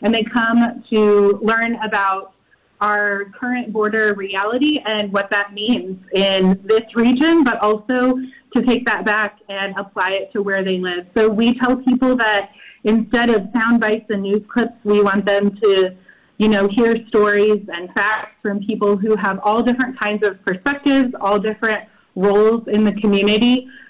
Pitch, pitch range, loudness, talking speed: 215 Hz, 200-235 Hz, -17 LUFS, 170 wpm